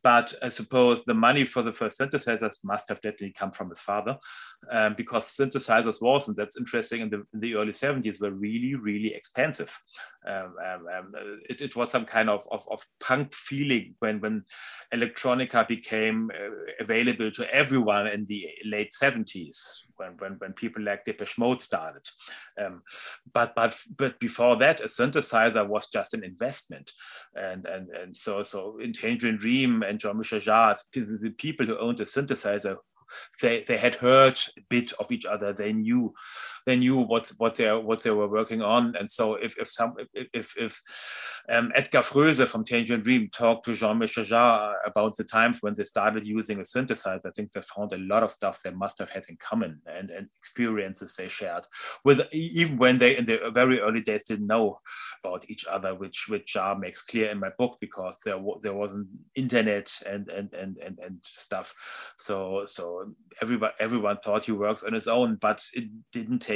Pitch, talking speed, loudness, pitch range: 110 Hz, 185 wpm, -26 LUFS, 105-125 Hz